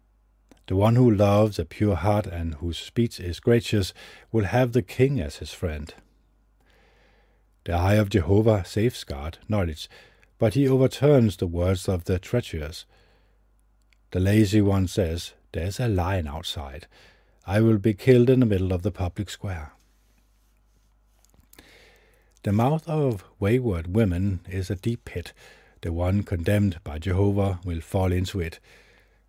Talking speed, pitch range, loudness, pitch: 145 wpm, 90-110 Hz, -24 LUFS, 100 Hz